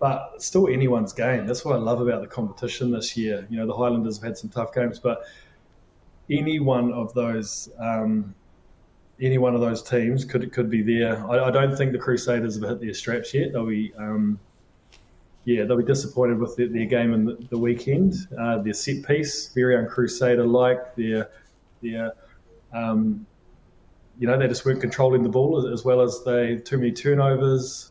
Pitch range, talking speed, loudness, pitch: 110-125 Hz, 190 wpm, -23 LUFS, 120 Hz